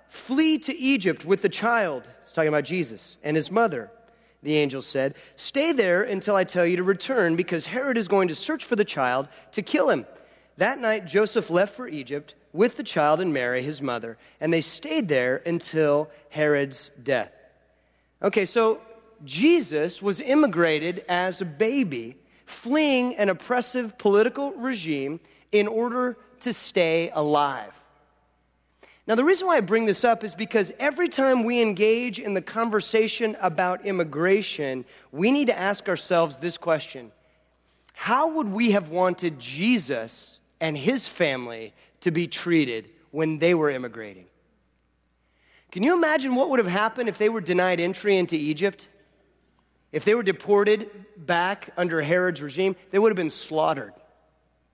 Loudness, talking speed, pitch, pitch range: -24 LUFS, 155 wpm, 185 Hz, 150-225 Hz